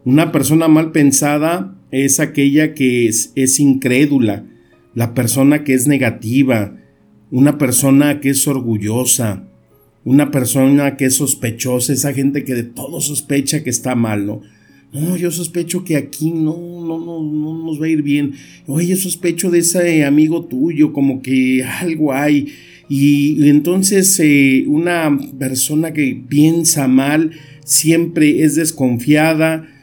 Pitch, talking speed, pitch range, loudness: 145 Hz, 145 wpm, 130-155 Hz, -14 LUFS